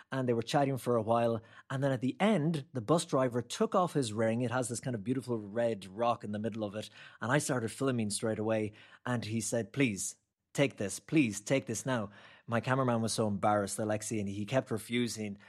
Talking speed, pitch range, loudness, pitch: 225 wpm, 110-130 Hz, -33 LUFS, 120 Hz